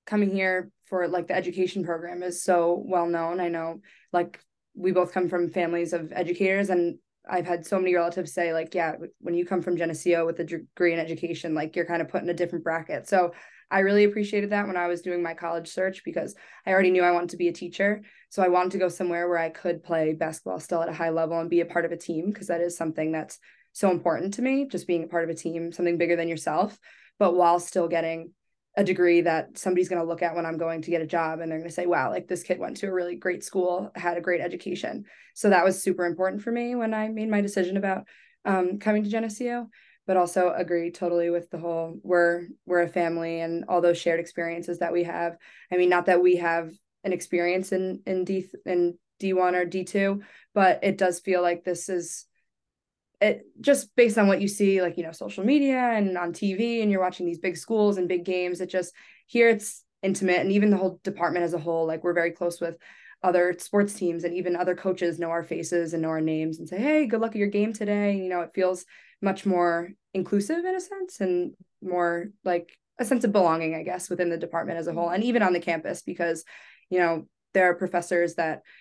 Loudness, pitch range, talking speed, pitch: -26 LUFS, 170-190 Hz, 240 wpm, 180 Hz